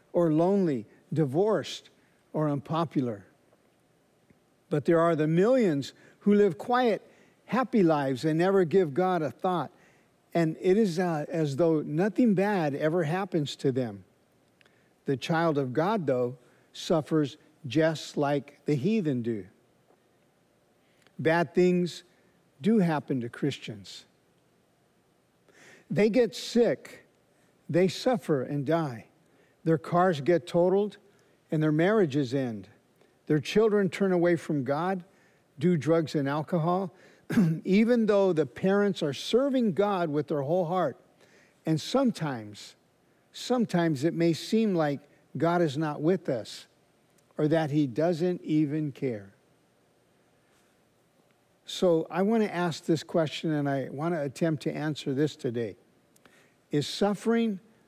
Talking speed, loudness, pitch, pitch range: 125 wpm, -27 LUFS, 165 Hz, 150-185 Hz